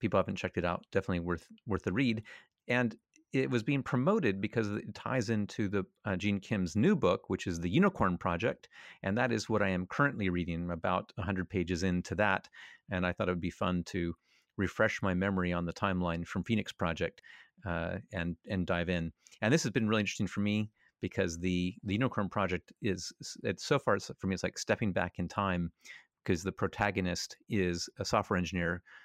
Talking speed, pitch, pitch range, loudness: 200 wpm, 95 Hz, 90-105 Hz, -33 LUFS